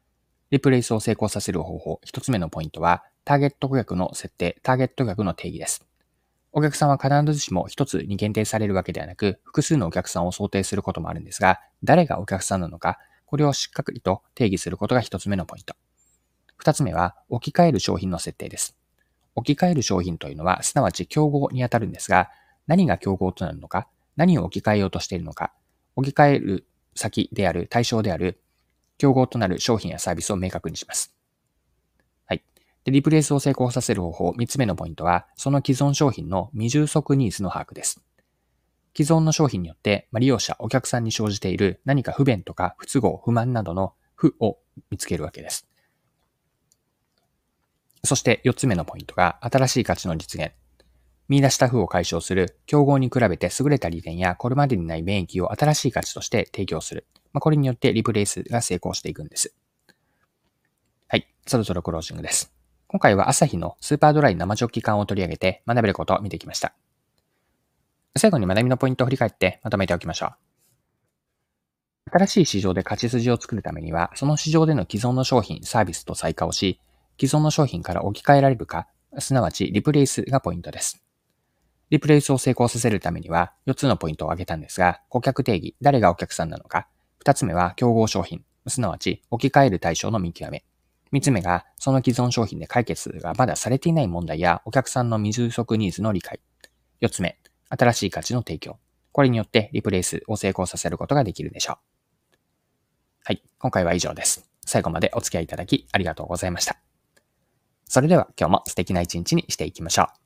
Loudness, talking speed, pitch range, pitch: -23 LUFS, 400 characters per minute, 90-130 Hz, 105 Hz